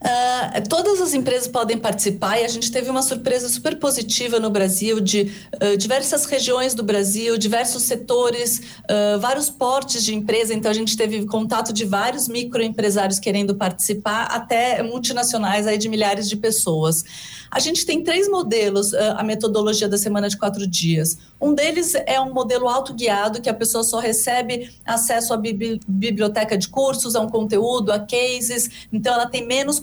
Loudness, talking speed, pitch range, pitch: -20 LUFS, 170 wpm, 210-250 Hz, 230 Hz